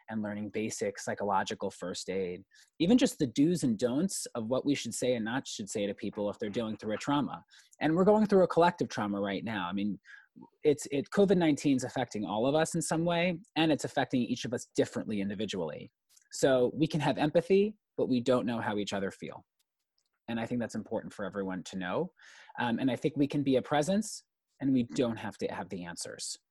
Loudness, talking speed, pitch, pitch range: -31 LUFS, 220 wpm, 135 Hz, 110-165 Hz